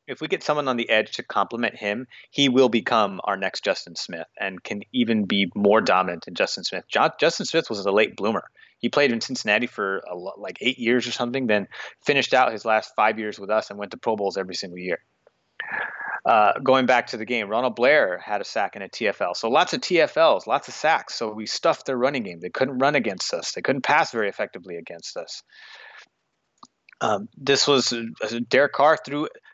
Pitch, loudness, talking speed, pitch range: 120 Hz, -23 LUFS, 220 wpm, 110-145 Hz